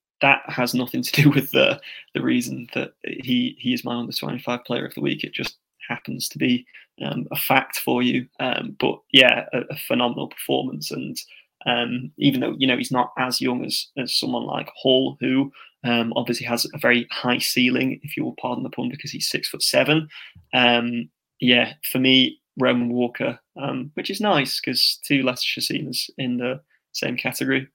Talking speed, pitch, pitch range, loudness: 190 wpm, 125 Hz, 120-140 Hz, -22 LUFS